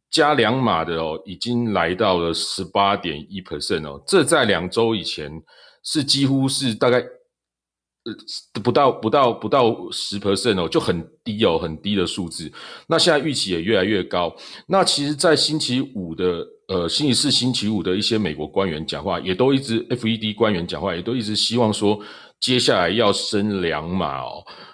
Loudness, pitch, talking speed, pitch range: -20 LUFS, 110 Hz, 285 characters per minute, 95-130 Hz